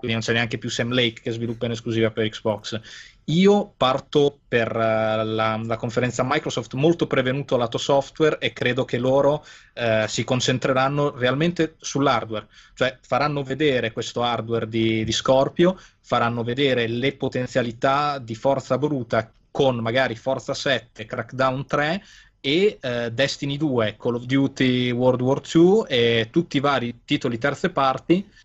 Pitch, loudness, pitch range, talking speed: 130 Hz, -22 LUFS, 115-140 Hz, 150 wpm